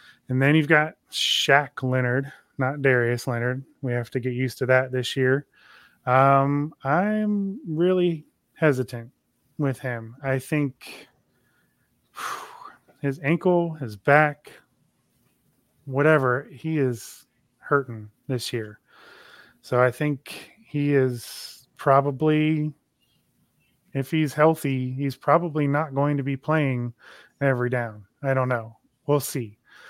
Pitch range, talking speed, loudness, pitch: 125-150 Hz, 120 wpm, -24 LUFS, 135 Hz